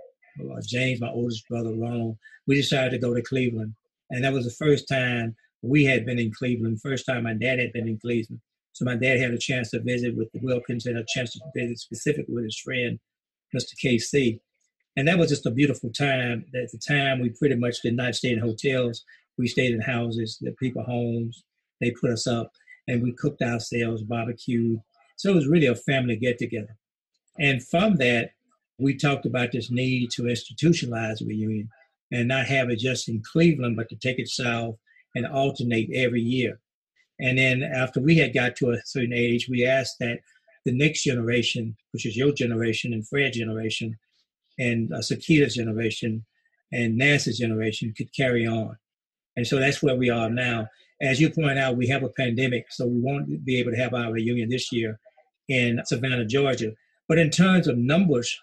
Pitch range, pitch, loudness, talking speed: 115-135 Hz, 125 Hz, -25 LUFS, 195 wpm